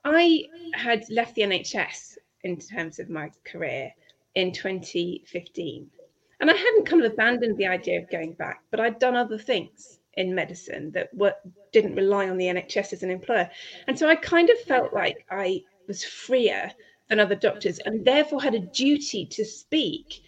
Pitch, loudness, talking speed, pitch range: 220 Hz, -25 LUFS, 180 wpm, 185-300 Hz